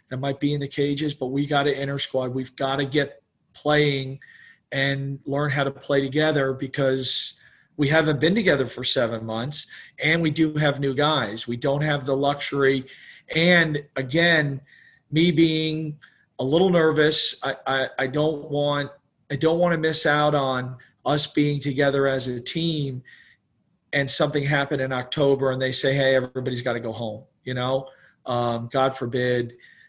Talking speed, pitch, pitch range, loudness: 175 wpm, 140 Hz, 130-150 Hz, -22 LUFS